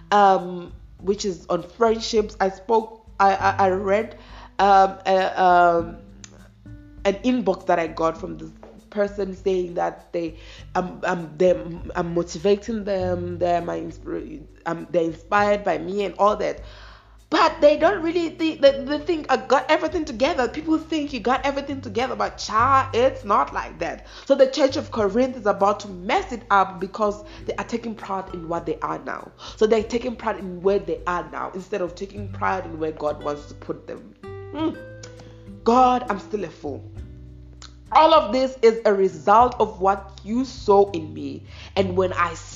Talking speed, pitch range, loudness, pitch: 185 wpm, 170-230 Hz, -22 LUFS, 195 Hz